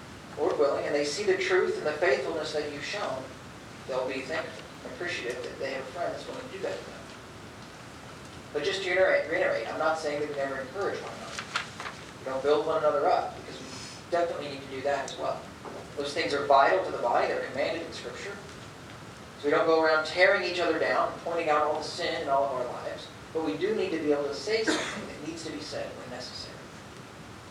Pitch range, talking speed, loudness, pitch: 145-170 Hz, 230 wpm, -29 LUFS, 155 Hz